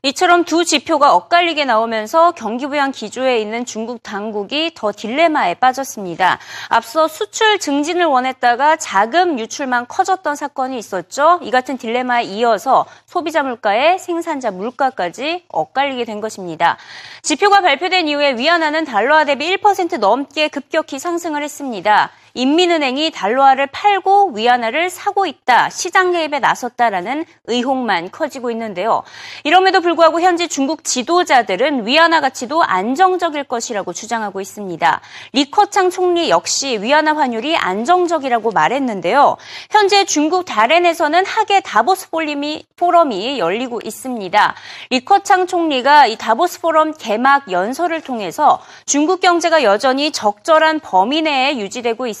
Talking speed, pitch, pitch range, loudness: 345 characters per minute, 290 Hz, 240-345 Hz, -15 LUFS